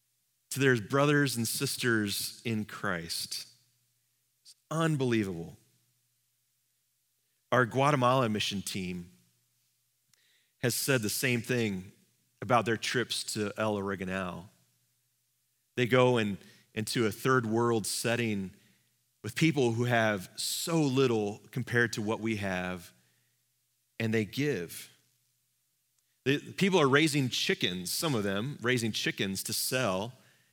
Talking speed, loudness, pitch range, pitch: 115 wpm, -30 LUFS, 105-125 Hz, 120 Hz